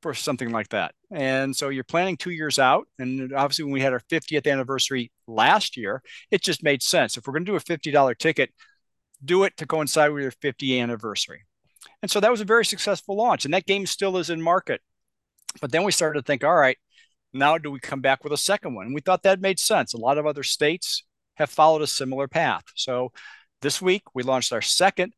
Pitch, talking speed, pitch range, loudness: 150 Hz, 230 wpm, 135-180 Hz, -23 LUFS